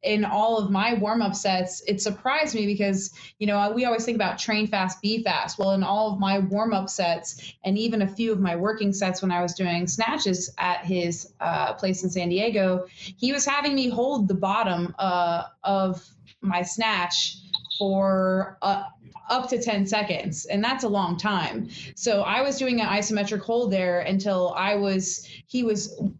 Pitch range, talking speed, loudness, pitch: 185-215 Hz, 190 wpm, -25 LUFS, 195 Hz